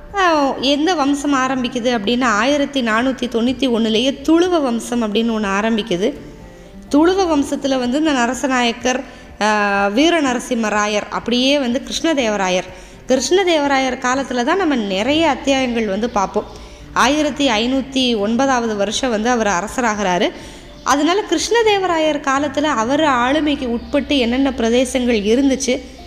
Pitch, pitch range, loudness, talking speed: 255 Hz, 230-285 Hz, -17 LUFS, 105 wpm